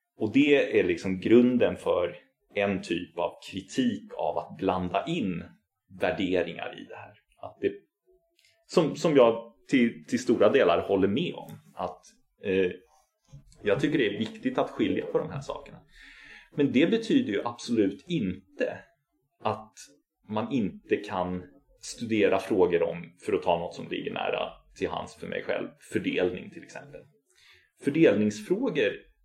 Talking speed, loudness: 150 wpm, -28 LUFS